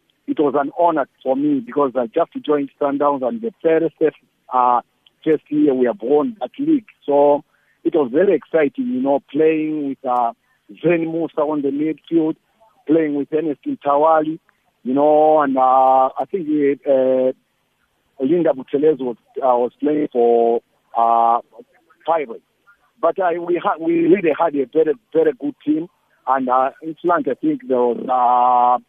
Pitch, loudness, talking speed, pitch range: 150 Hz, -18 LUFS, 165 wpm, 130-165 Hz